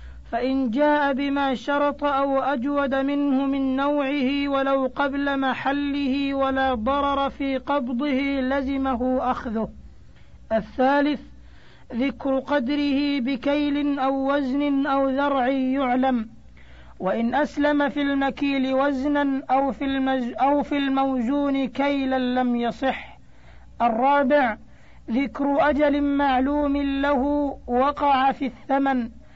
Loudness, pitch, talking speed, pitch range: -23 LUFS, 275 Hz, 95 wpm, 260-285 Hz